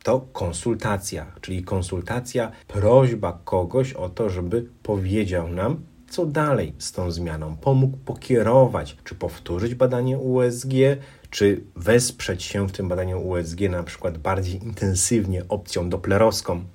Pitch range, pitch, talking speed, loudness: 90-120 Hz, 100 Hz, 125 wpm, -23 LUFS